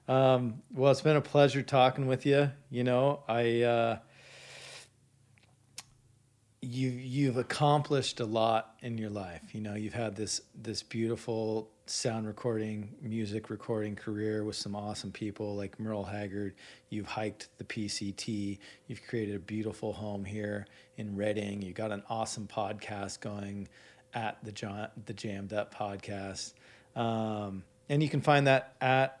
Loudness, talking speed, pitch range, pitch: -33 LUFS, 145 wpm, 105-125 Hz, 110 Hz